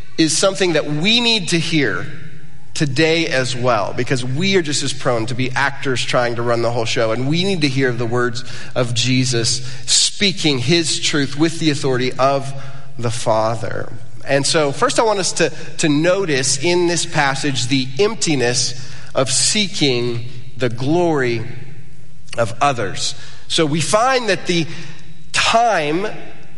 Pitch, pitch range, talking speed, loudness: 140 Hz, 125-160 Hz, 155 wpm, -17 LUFS